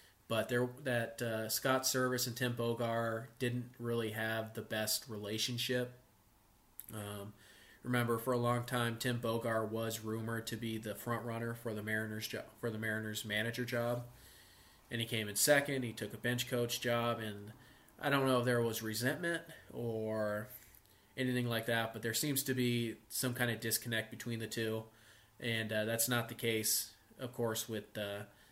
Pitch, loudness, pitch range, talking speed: 115 Hz, -37 LUFS, 110-120 Hz, 175 wpm